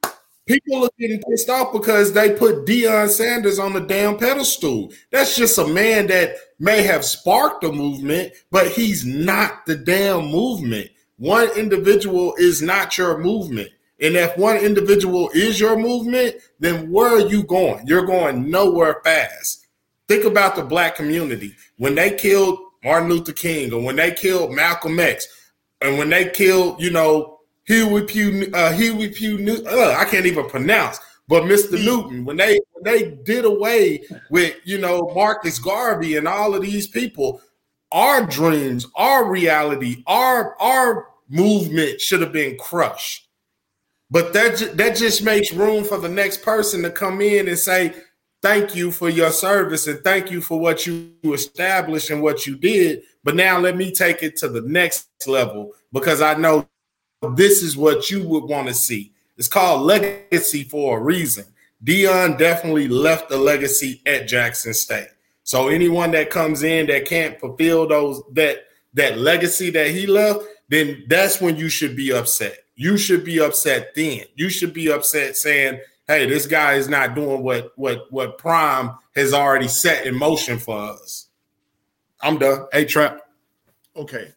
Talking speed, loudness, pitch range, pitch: 170 wpm, -18 LUFS, 150-205 Hz, 175 Hz